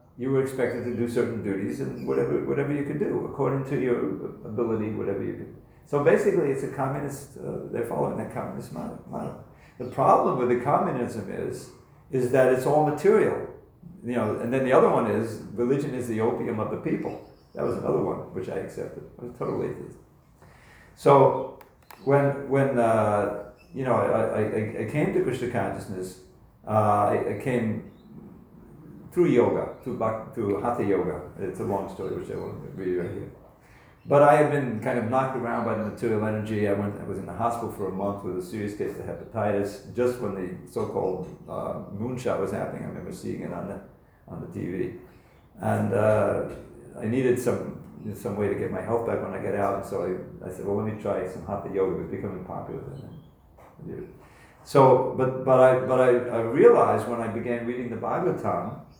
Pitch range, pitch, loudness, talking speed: 105-130 Hz, 120 Hz, -26 LUFS, 195 wpm